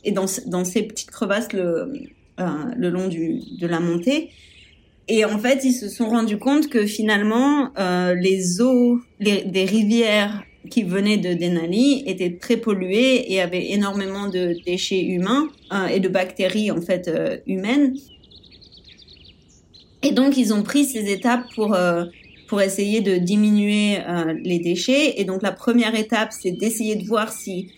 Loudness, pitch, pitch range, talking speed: -20 LUFS, 205 Hz, 185-235 Hz, 165 wpm